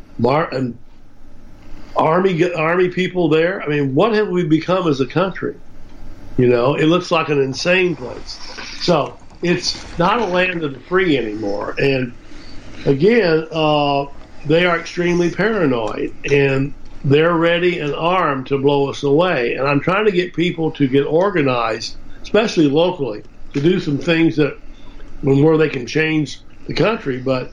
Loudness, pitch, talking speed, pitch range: -17 LUFS, 150 Hz, 155 wpm, 135-175 Hz